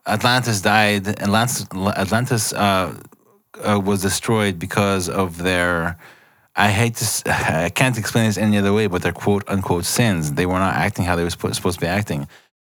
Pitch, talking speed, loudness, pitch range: 100 Hz, 175 wpm, -19 LUFS, 90-110 Hz